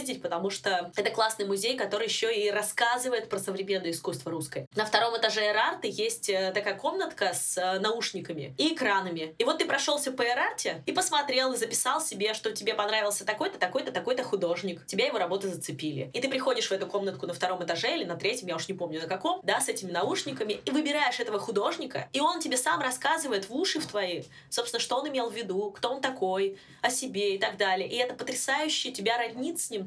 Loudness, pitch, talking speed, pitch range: -29 LUFS, 220 Hz, 205 wpm, 195-260 Hz